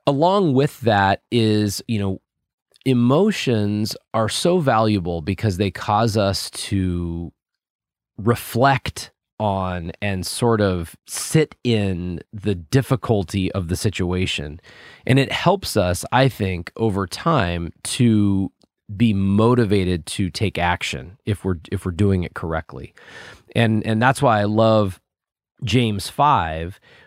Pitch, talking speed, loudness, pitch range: 105 Hz, 125 wpm, -20 LUFS, 95-120 Hz